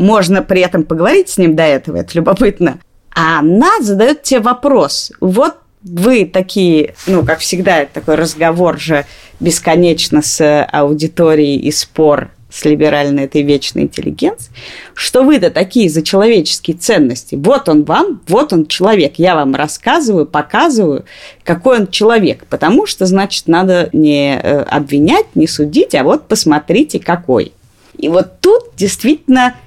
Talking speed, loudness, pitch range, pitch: 140 wpm, -11 LUFS, 150-210 Hz, 170 Hz